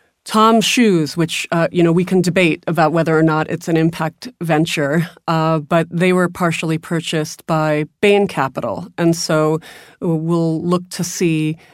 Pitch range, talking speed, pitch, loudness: 160-175 Hz, 165 wpm, 165 Hz, -16 LUFS